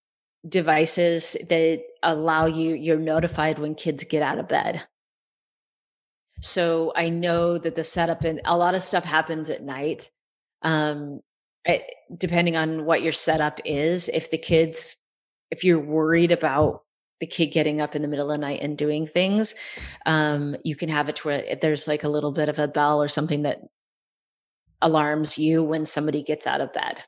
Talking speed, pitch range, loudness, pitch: 175 wpm, 150-165 Hz, -23 LUFS, 160 Hz